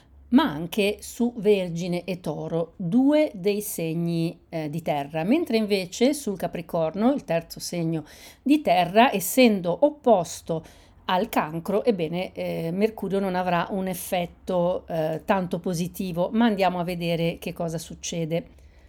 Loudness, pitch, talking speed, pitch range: -25 LUFS, 180 Hz, 135 wpm, 165-210 Hz